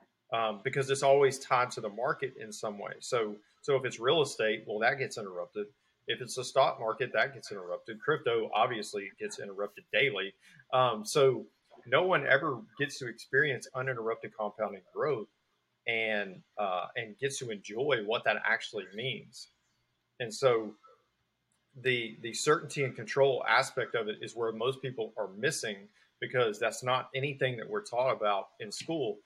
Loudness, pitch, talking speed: -32 LUFS, 135 Hz, 165 wpm